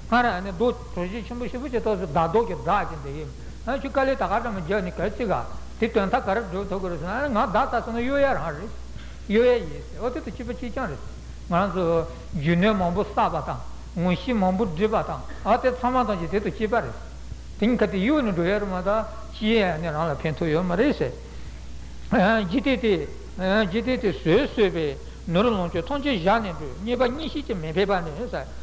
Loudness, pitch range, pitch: -24 LUFS, 180-240 Hz, 210 Hz